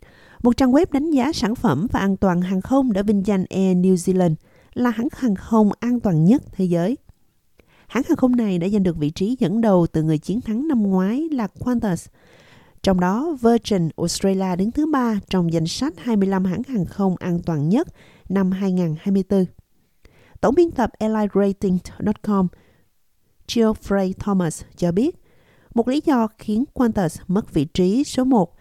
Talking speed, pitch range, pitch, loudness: 175 wpm, 185-240 Hz, 200 Hz, -20 LUFS